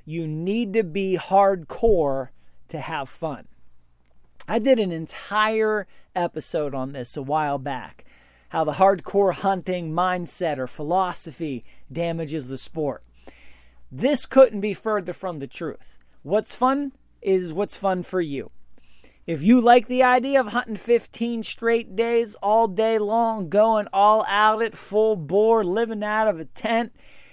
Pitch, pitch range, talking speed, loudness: 195 Hz, 155-225 Hz, 145 wpm, -22 LUFS